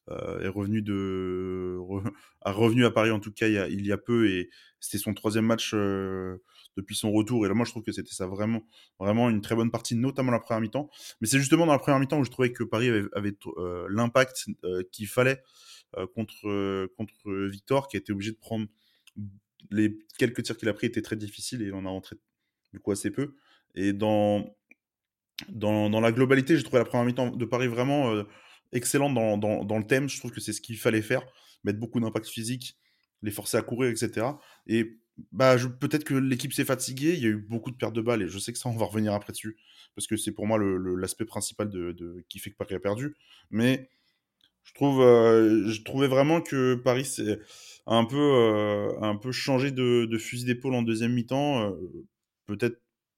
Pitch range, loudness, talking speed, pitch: 105-125 Hz, -27 LUFS, 225 wpm, 110 Hz